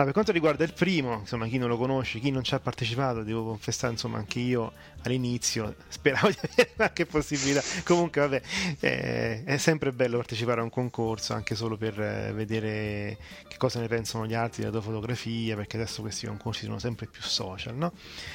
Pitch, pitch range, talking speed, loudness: 120 Hz, 110-135 Hz, 195 wpm, -29 LUFS